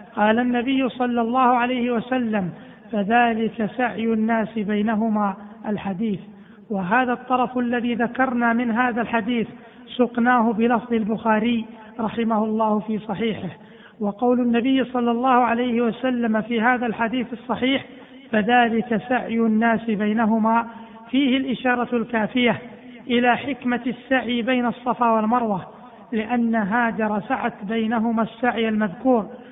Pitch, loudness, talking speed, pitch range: 230 Hz, -22 LUFS, 110 wpm, 220-245 Hz